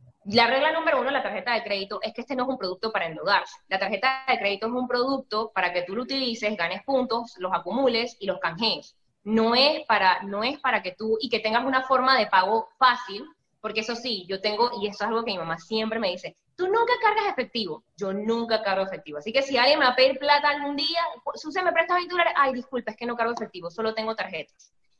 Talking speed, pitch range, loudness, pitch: 245 wpm, 205-265 Hz, -25 LUFS, 230 Hz